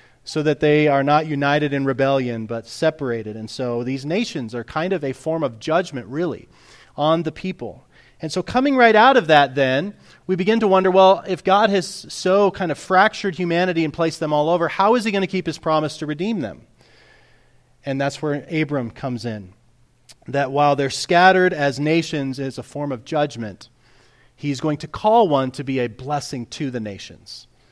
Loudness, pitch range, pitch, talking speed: -19 LUFS, 130-175 Hz, 145 Hz, 195 wpm